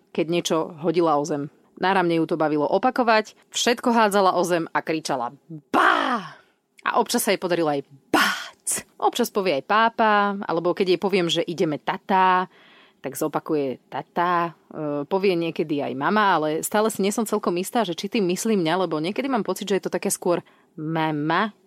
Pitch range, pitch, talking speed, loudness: 160-205 Hz, 180 Hz, 175 wpm, -23 LUFS